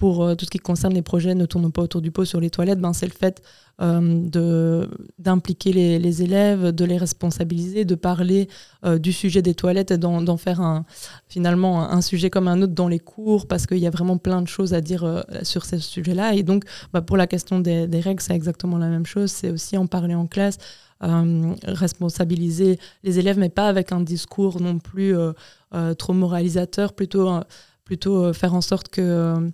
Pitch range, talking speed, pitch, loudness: 170-190 Hz, 220 wpm, 180 Hz, -21 LUFS